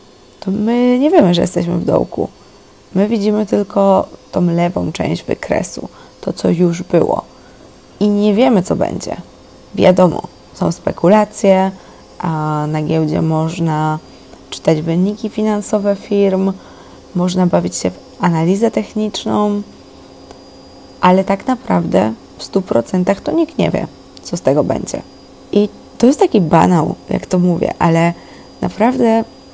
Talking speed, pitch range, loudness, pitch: 130 wpm, 170-210 Hz, -15 LUFS, 190 Hz